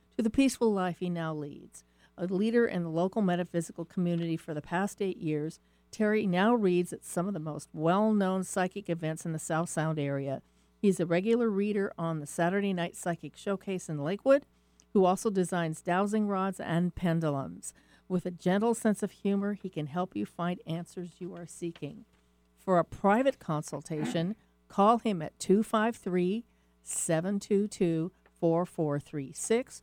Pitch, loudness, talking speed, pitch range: 175 Hz, -31 LUFS, 160 wpm, 160-200 Hz